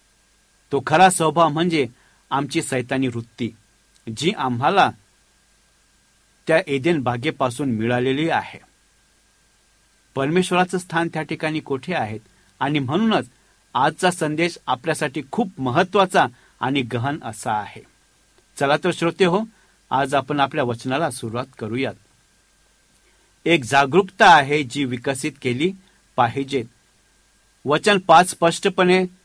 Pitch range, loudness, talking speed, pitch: 125-170 Hz, -20 LUFS, 105 wpm, 145 Hz